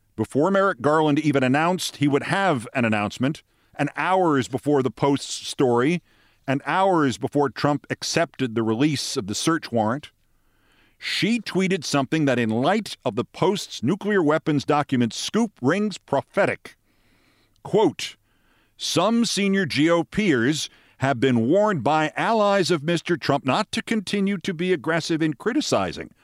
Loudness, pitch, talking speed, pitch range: -22 LUFS, 150 Hz, 145 wpm, 135-185 Hz